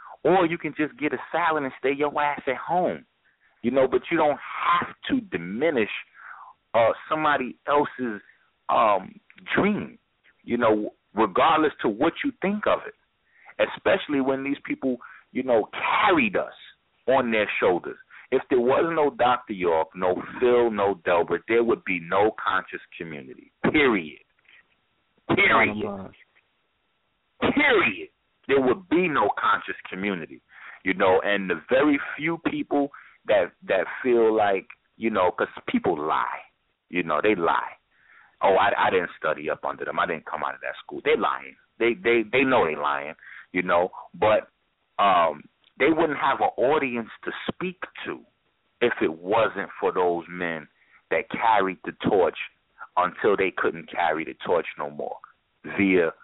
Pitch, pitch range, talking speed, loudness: 130 Hz, 110-155 Hz, 155 wpm, -24 LUFS